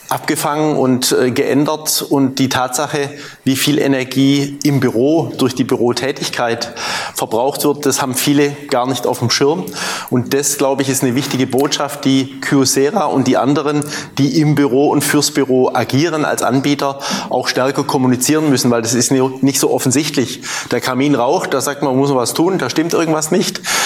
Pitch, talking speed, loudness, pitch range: 140 Hz, 175 wpm, -15 LUFS, 130-145 Hz